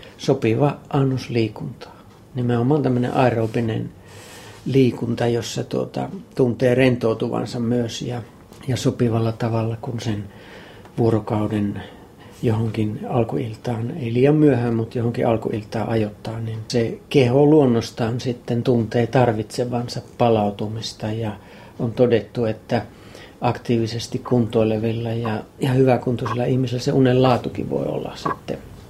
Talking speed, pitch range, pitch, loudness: 110 wpm, 110-125 Hz, 120 Hz, -21 LUFS